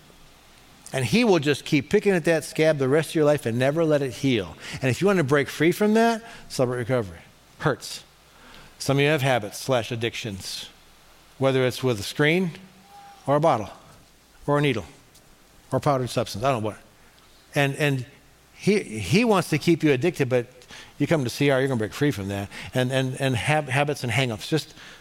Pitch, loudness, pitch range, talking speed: 140 Hz, -23 LUFS, 125-155 Hz, 205 wpm